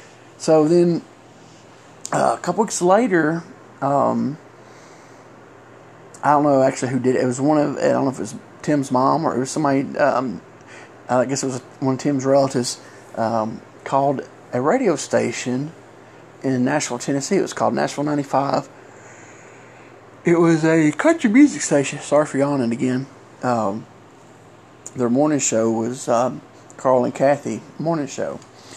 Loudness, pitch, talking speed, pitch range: -20 LUFS, 135 Hz, 155 wpm, 125-150 Hz